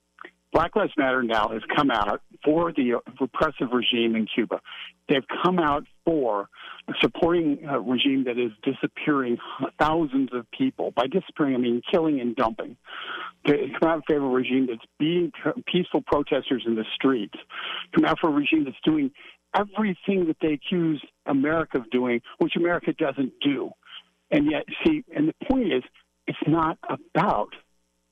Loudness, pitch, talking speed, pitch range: -25 LUFS, 150 Hz, 160 wpm, 125-180 Hz